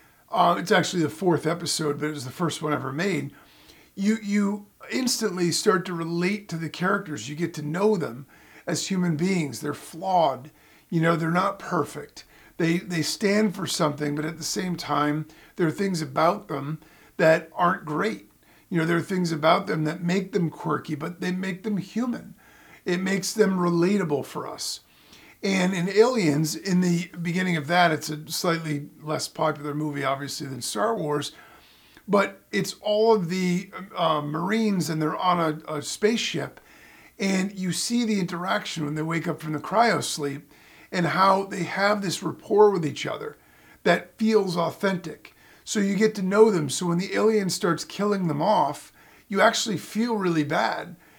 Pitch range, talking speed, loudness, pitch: 155-200 Hz, 180 wpm, -25 LUFS, 175 Hz